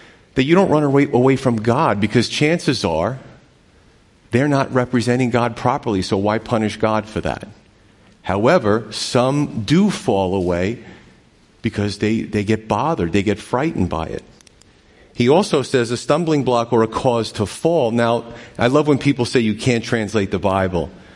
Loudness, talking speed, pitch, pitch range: -18 LUFS, 165 wpm, 115 Hz, 105-130 Hz